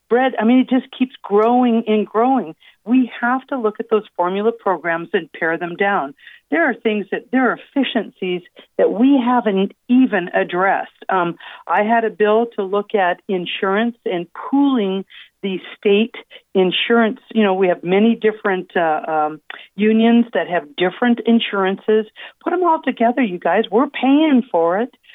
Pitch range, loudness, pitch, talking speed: 190-245 Hz, -18 LUFS, 220 Hz, 165 wpm